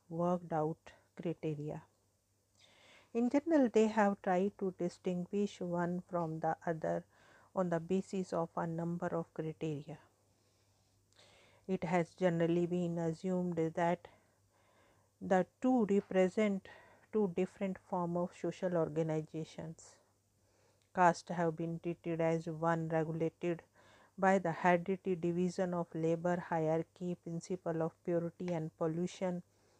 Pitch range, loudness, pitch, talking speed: 160-185 Hz, -36 LUFS, 170 Hz, 115 wpm